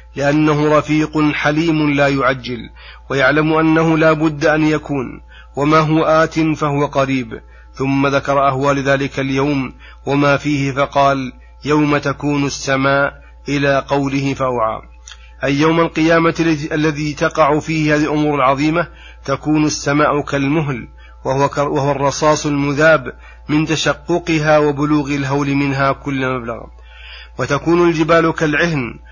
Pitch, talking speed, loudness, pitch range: 145 Hz, 115 wpm, -15 LUFS, 135-155 Hz